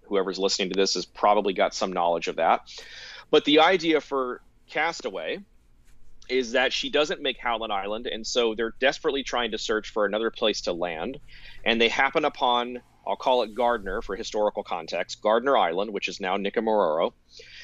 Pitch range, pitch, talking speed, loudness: 95-135 Hz, 115 Hz, 175 wpm, -25 LUFS